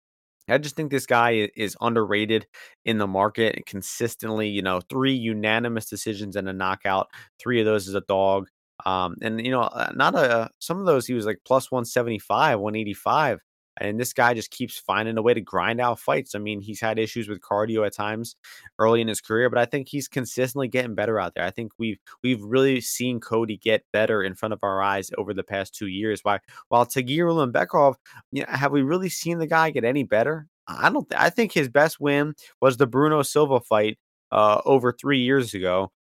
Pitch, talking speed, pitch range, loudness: 115 Hz, 215 wpm, 105-130 Hz, -23 LUFS